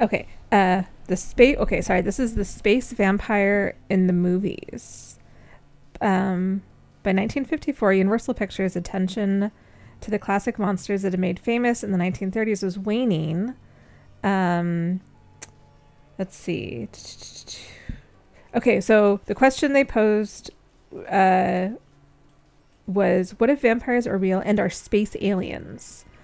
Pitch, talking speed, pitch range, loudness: 200 Hz, 120 wpm, 185-215 Hz, -22 LUFS